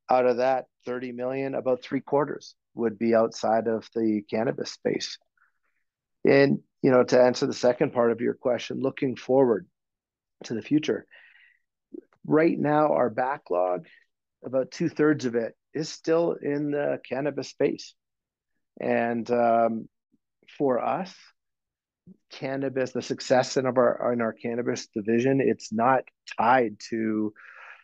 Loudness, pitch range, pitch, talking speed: -26 LUFS, 115-140 Hz, 125 Hz, 135 wpm